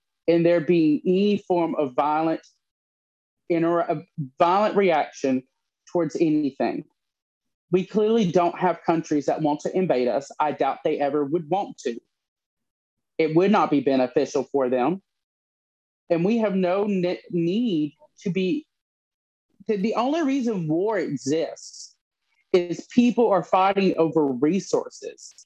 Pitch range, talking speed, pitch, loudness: 155-205 Hz, 130 wpm, 175 Hz, -23 LUFS